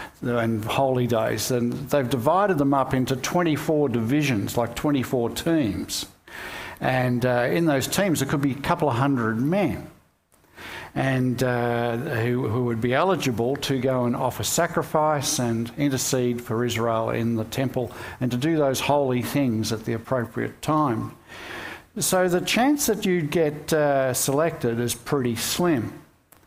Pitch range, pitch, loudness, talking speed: 120-150 Hz, 130 Hz, -23 LUFS, 150 wpm